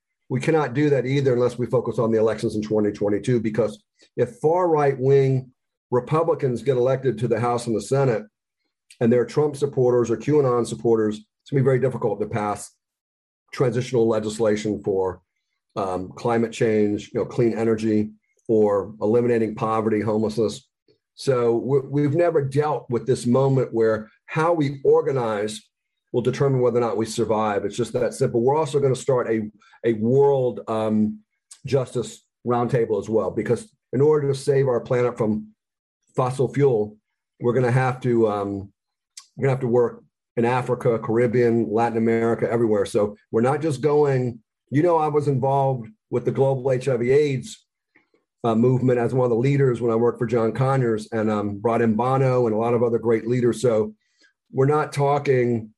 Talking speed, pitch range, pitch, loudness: 175 wpm, 110-135 Hz, 120 Hz, -22 LUFS